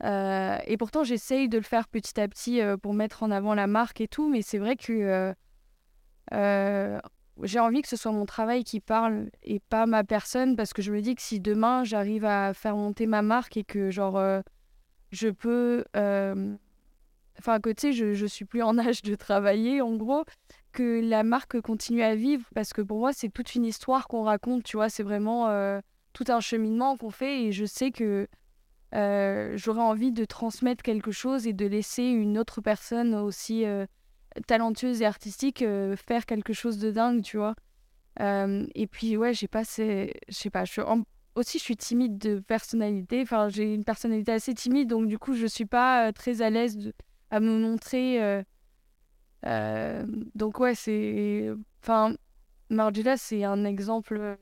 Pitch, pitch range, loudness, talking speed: 220 Hz, 205-235 Hz, -28 LUFS, 190 wpm